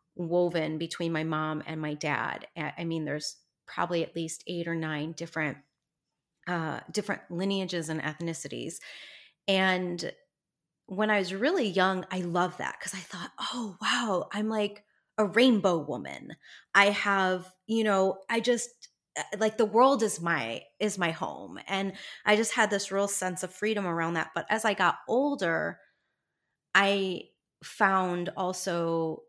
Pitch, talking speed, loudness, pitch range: 185 Hz, 150 wpm, -29 LUFS, 165-205 Hz